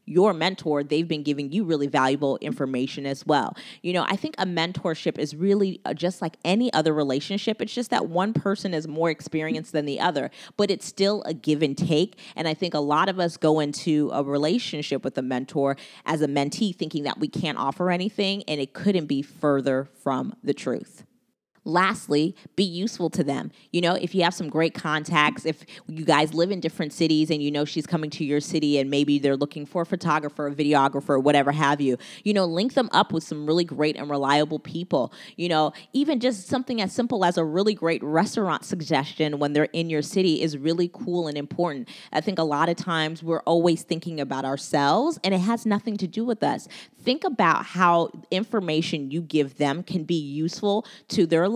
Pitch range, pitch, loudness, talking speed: 150-185 Hz, 165 Hz, -25 LUFS, 210 wpm